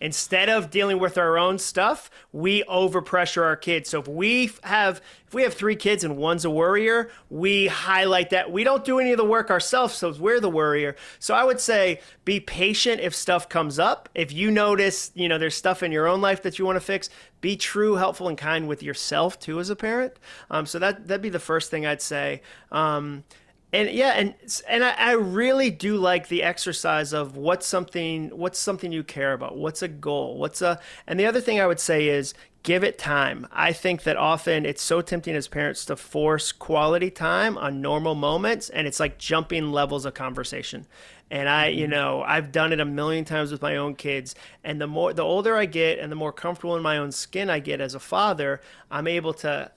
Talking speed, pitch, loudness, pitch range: 220 wpm, 175 Hz, -23 LUFS, 155-195 Hz